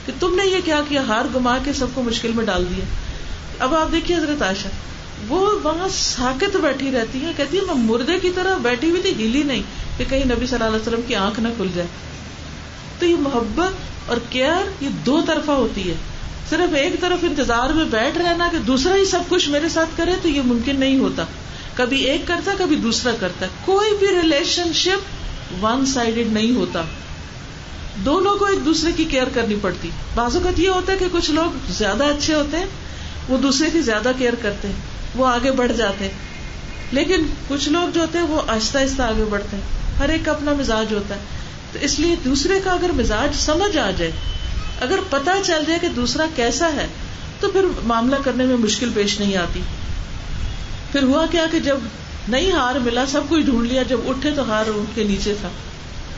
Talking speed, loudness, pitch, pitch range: 200 wpm, -19 LUFS, 275 Hz, 235-335 Hz